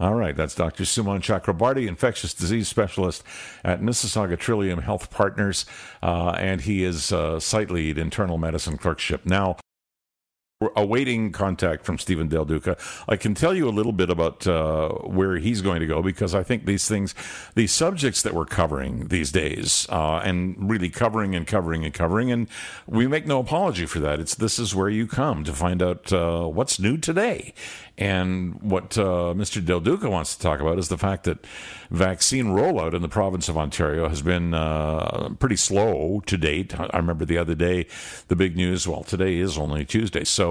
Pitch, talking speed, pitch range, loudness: 95 Hz, 190 wpm, 85-105 Hz, -24 LUFS